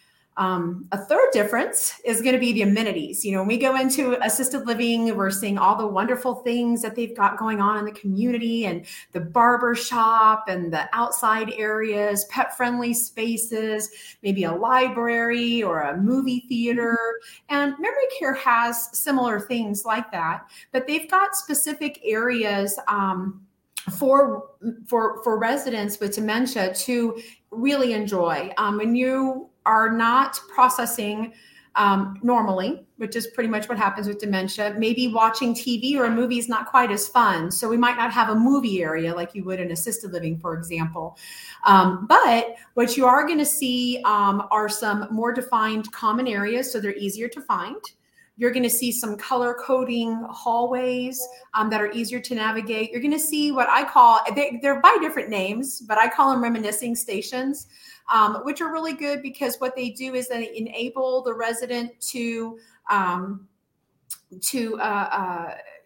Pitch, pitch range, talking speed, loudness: 230 Hz, 210-255 Hz, 170 wpm, -22 LUFS